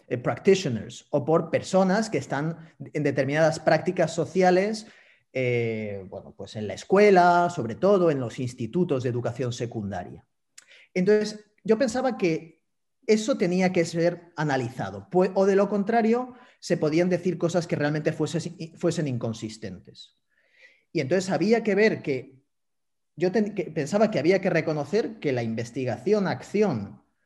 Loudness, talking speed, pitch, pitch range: -25 LUFS, 145 wpm, 165 Hz, 135-190 Hz